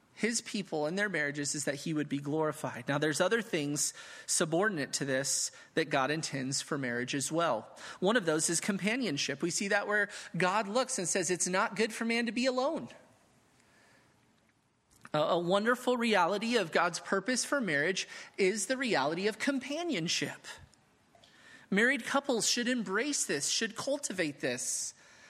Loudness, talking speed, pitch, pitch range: -31 LUFS, 160 wpm, 195 Hz, 150-235 Hz